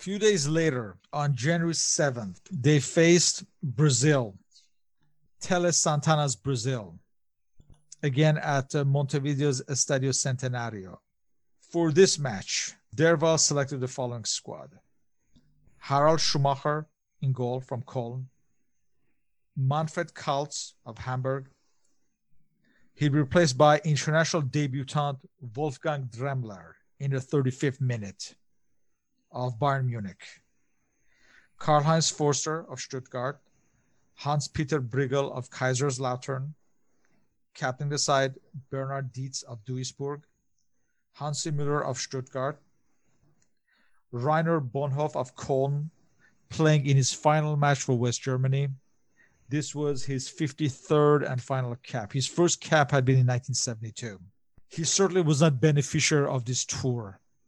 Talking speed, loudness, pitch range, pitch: 105 wpm, -27 LUFS, 130-150 Hz, 140 Hz